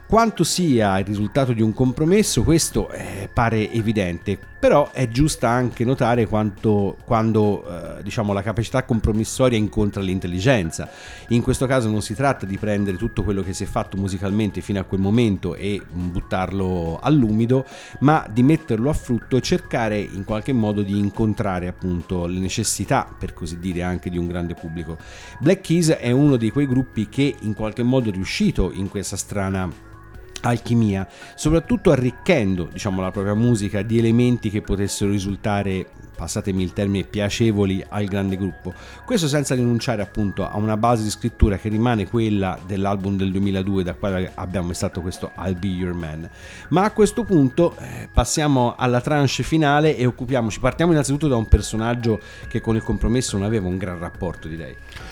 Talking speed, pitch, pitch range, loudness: 170 wpm, 105 Hz, 95-125 Hz, -21 LUFS